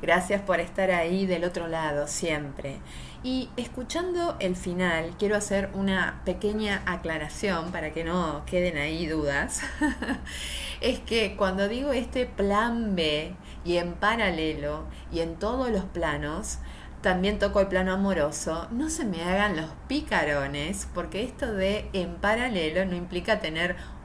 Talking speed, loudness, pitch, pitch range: 140 wpm, -28 LUFS, 185 Hz, 165-210 Hz